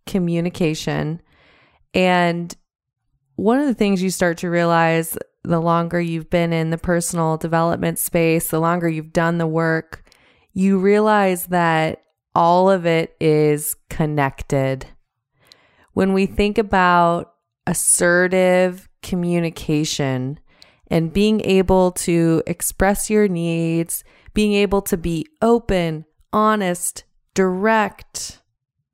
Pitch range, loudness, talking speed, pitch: 160-190 Hz, -19 LUFS, 110 wpm, 170 Hz